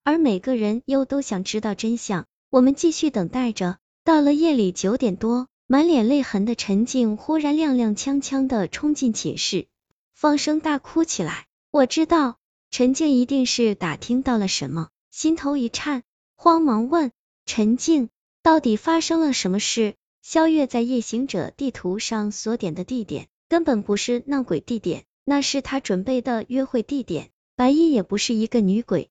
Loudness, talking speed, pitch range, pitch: -22 LUFS, 250 characters per minute, 215-285 Hz, 250 Hz